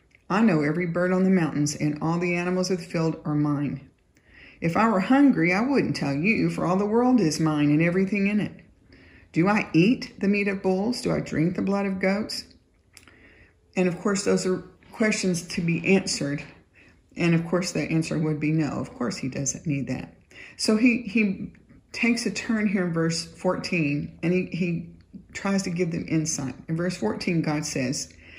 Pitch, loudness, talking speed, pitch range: 180 Hz, -25 LUFS, 200 wpm, 155-200 Hz